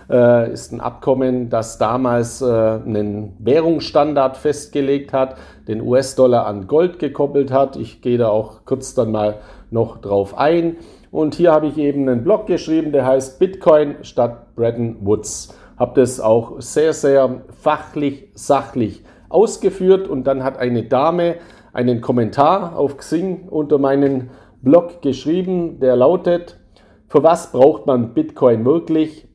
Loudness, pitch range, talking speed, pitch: -17 LUFS, 120-155 Hz, 140 wpm, 135 Hz